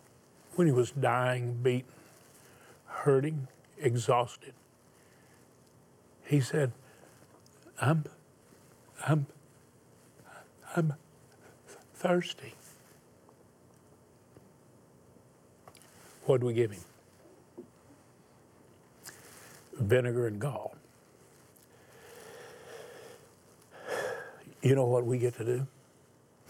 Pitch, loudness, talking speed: 125 Hz, -31 LUFS, 65 wpm